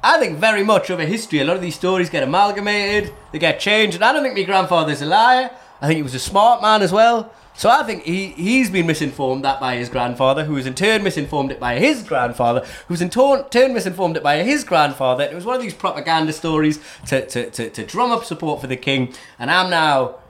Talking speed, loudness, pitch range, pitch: 250 wpm, -18 LUFS, 145-215 Hz, 175 Hz